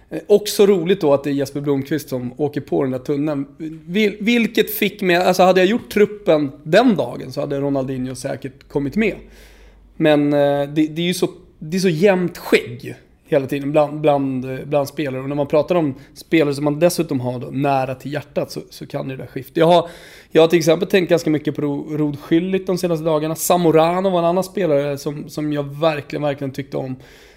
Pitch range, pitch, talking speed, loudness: 140-175 Hz, 150 Hz, 210 wpm, -18 LUFS